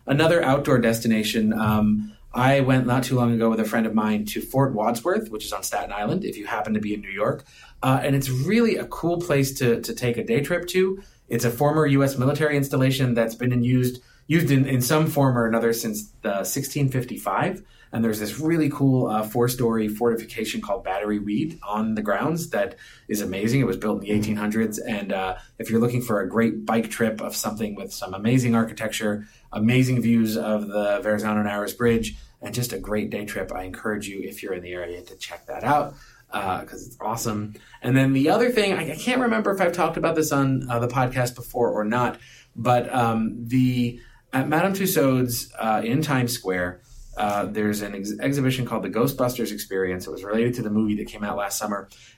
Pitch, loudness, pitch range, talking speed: 120 Hz, -23 LUFS, 105-135 Hz, 215 wpm